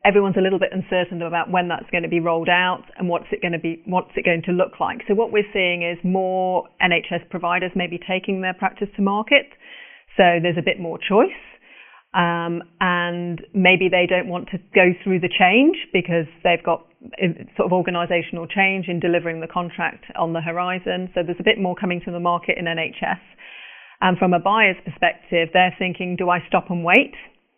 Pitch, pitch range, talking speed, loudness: 180 Hz, 175-190 Hz, 200 wpm, -20 LUFS